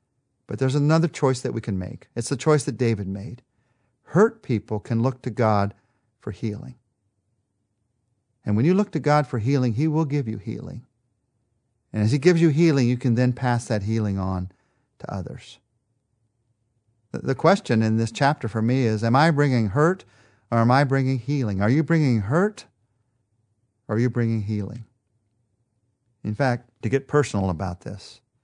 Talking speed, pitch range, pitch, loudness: 175 wpm, 110-135 Hz, 120 Hz, -23 LUFS